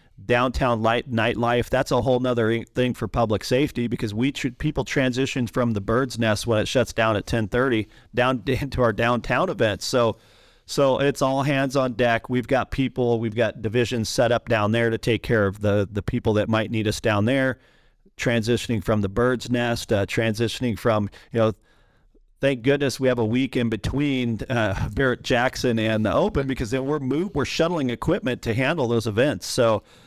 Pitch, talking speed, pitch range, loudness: 120 Hz, 195 wpm, 115-130 Hz, -23 LUFS